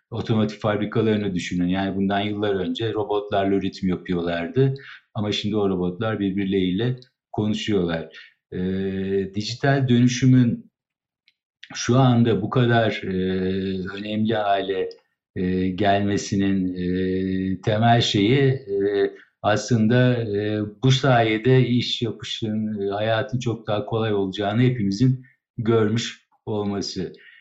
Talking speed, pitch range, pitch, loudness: 100 wpm, 95-120 Hz, 105 Hz, -22 LUFS